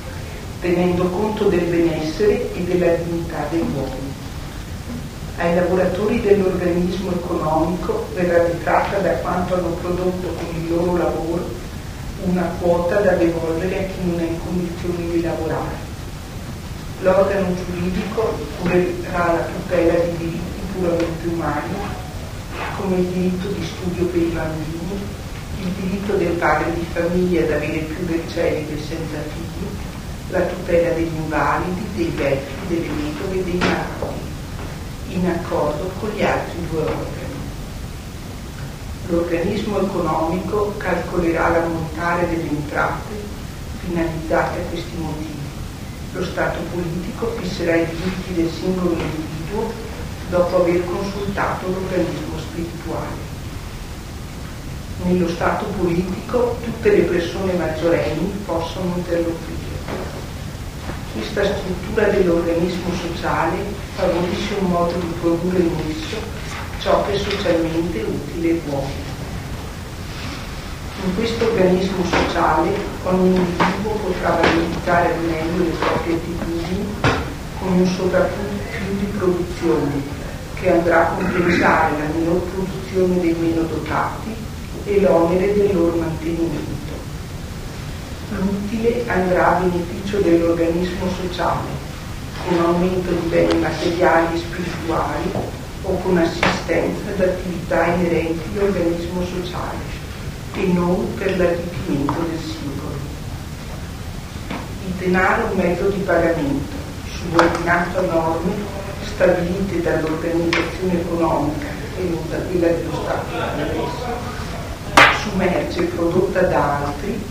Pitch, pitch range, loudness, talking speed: 175 Hz, 165-180 Hz, -20 LUFS, 115 wpm